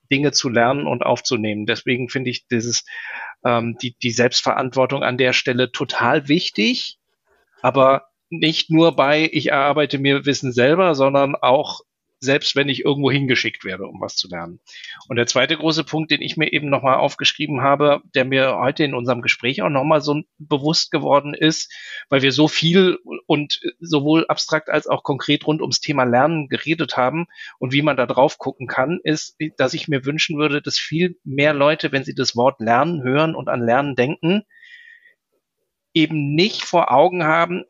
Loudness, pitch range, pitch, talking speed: -18 LUFS, 130-155 Hz, 145 Hz, 175 wpm